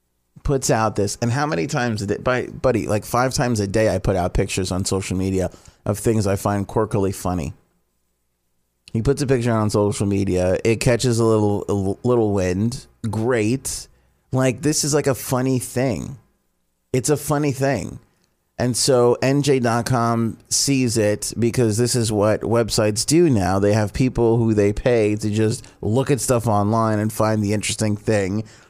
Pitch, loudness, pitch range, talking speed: 110 Hz, -20 LUFS, 100-125 Hz, 175 wpm